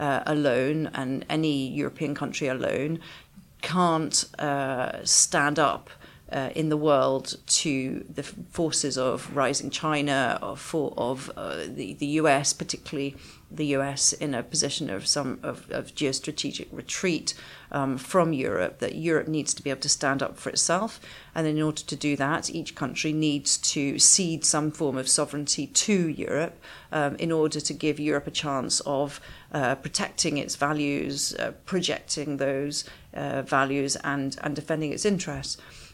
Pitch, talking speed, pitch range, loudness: 145 Hz, 155 wpm, 140-155 Hz, -26 LUFS